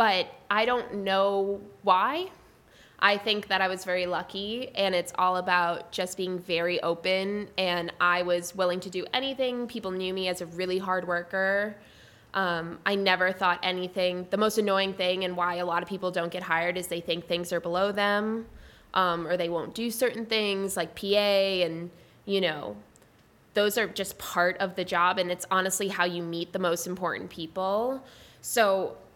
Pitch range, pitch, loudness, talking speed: 175-200 Hz, 185 Hz, -28 LUFS, 185 wpm